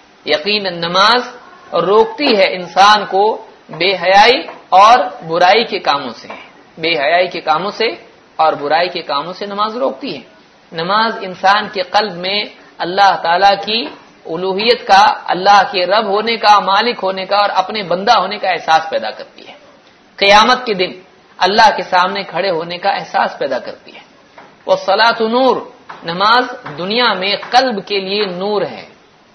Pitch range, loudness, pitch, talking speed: 185-225 Hz, -13 LUFS, 200 Hz, 155 wpm